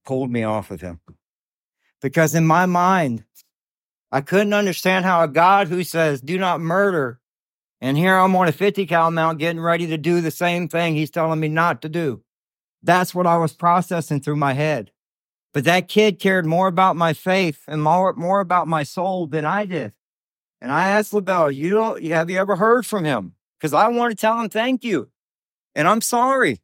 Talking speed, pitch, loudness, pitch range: 200 wpm, 170 Hz, -19 LUFS, 155-190 Hz